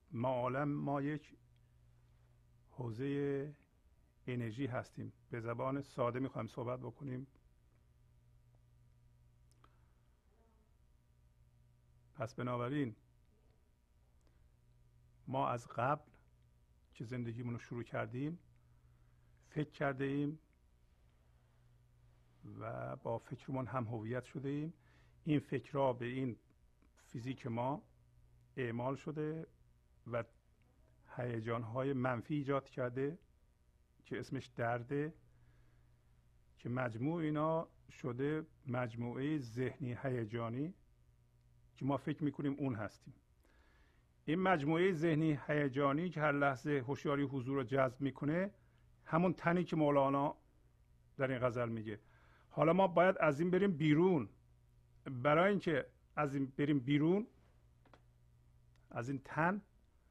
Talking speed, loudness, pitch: 100 wpm, -38 LUFS, 120 Hz